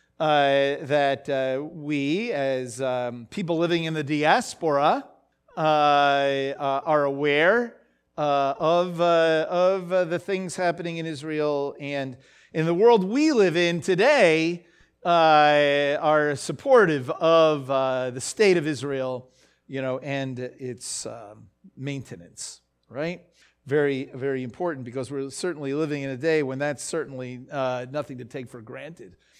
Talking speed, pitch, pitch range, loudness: 140 wpm, 145 Hz, 135-165 Hz, -23 LUFS